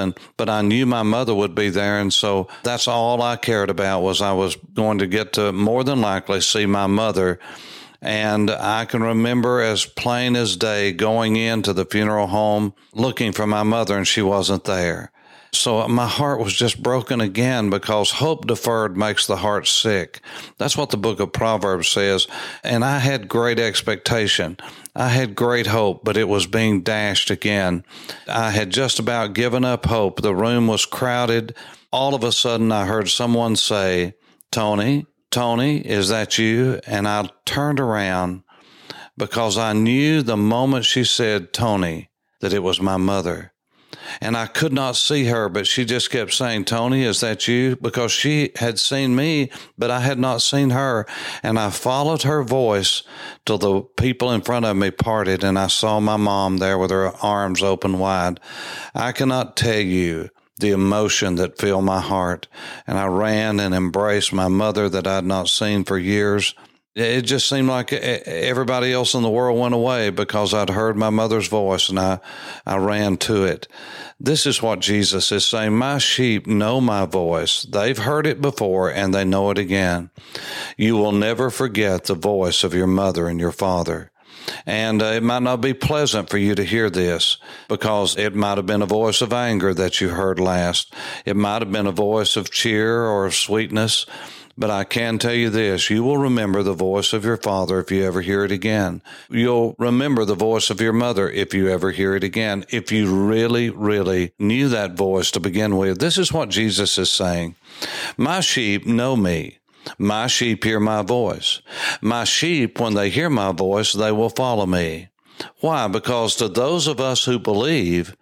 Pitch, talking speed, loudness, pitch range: 110 Hz, 185 wpm, -19 LUFS, 100-120 Hz